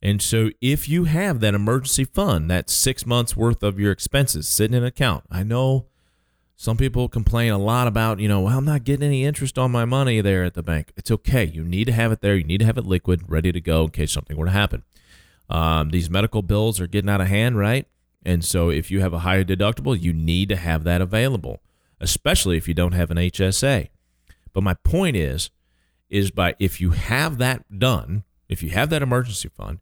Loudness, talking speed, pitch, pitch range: -21 LUFS, 225 wpm, 100 Hz, 85-120 Hz